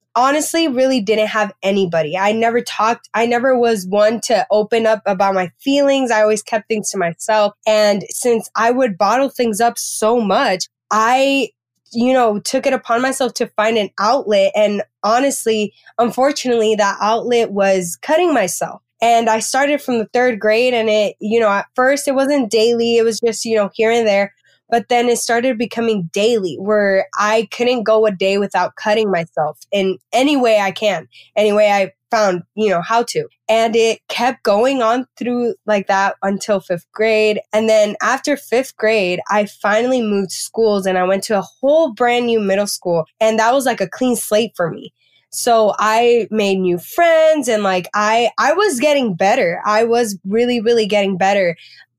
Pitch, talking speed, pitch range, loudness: 220 Hz, 185 wpm, 200-240 Hz, -16 LUFS